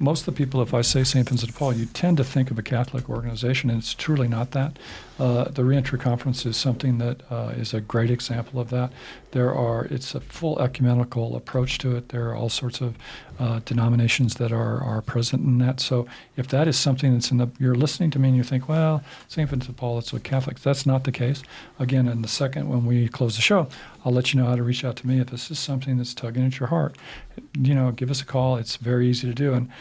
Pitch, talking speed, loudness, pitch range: 125 Hz, 255 wpm, -24 LUFS, 120-135 Hz